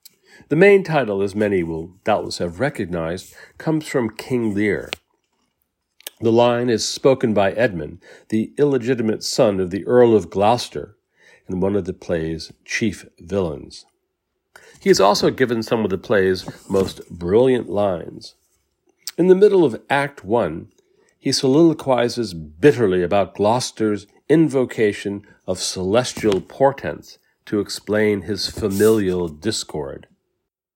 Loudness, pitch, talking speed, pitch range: -19 LUFS, 110 Hz, 125 wpm, 95-130 Hz